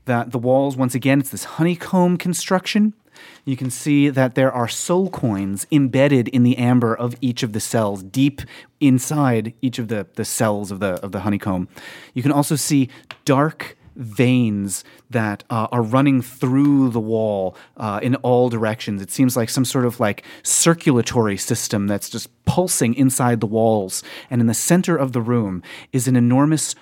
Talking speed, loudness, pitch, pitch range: 180 wpm, -19 LUFS, 125 Hz, 110-140 Hz